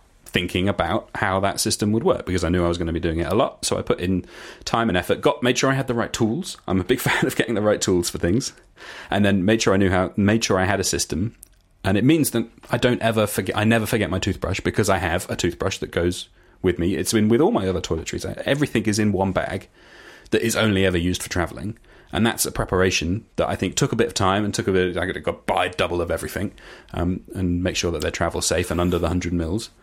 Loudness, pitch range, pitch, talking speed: -22 LUFS, 90-115 Hz, 95 Hz, 280 wpm